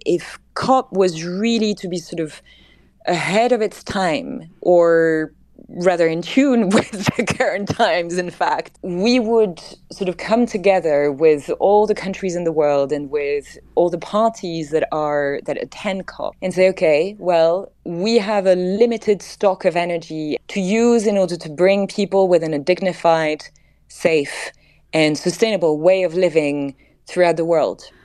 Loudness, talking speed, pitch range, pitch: -18 LUFS, 160 wpm, 165-210 Hz, 180 Hz